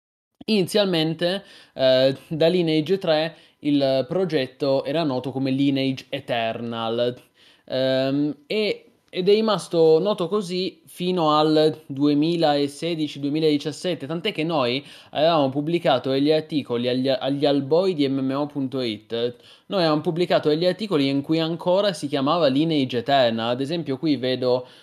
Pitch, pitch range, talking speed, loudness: 150 Hz, 135-170 Hz, 120 wpm, -22 LUFS